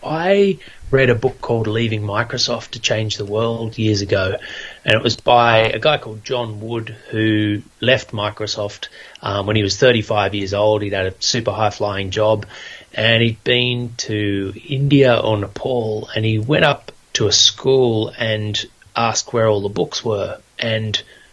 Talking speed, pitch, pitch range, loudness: 170 wpm, 110 Hz, 105-120 Hz, -18 LUFS